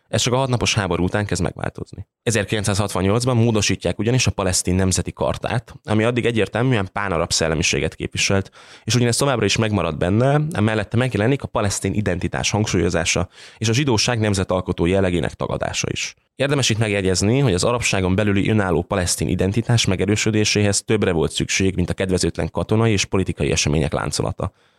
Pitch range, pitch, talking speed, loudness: 90-115 Hz, 100 Hz, 150 wpm, -20 LUFS